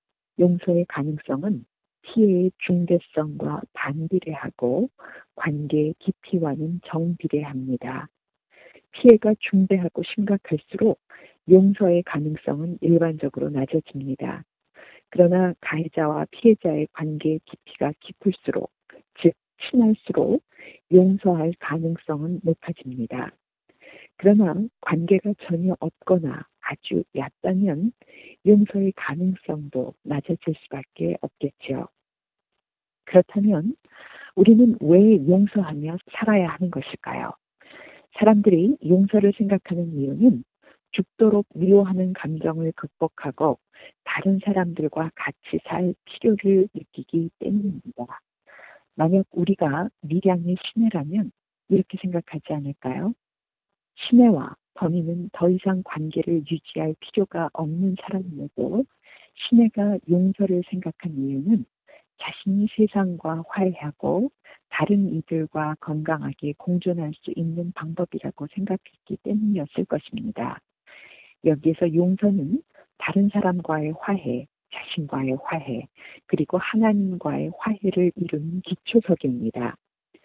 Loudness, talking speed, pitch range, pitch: -23 LUFS, 255 characters per minute, 155-200 Hz, 175 Hz